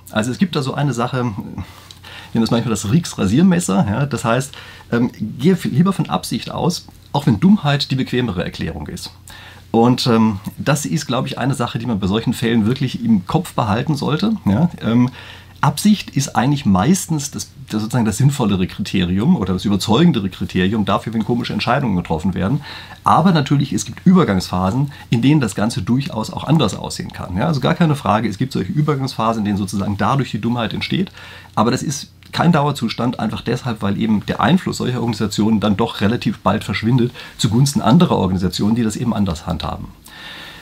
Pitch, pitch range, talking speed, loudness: 120 Hz, 105-145 Hz, 180 wpm, -18 LUFS